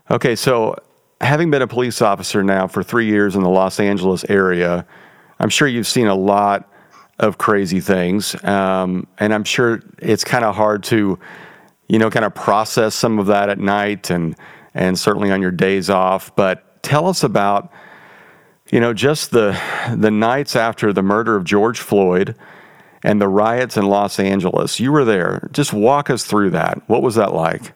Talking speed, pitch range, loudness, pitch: 185 wpm, 95-115 Hz, -16 LUFS, 100 Hz